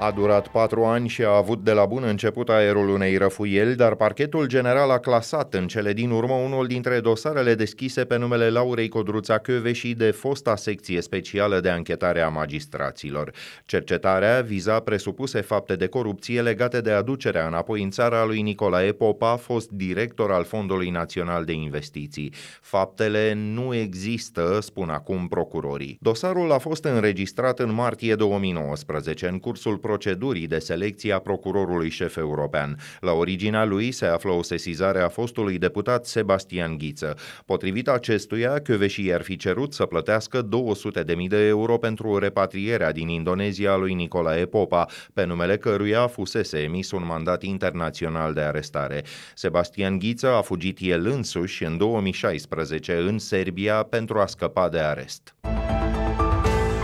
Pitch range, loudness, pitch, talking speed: 90-115 Hz, -24 LUFS, 105 Hz, 150 wpm